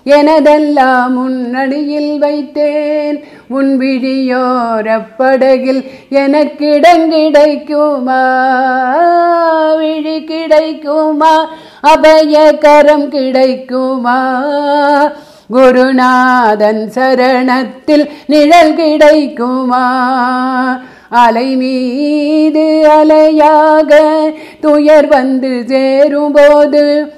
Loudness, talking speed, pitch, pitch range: -9 LUFS, 40 wpm, 290 Hz, 260-305 Hz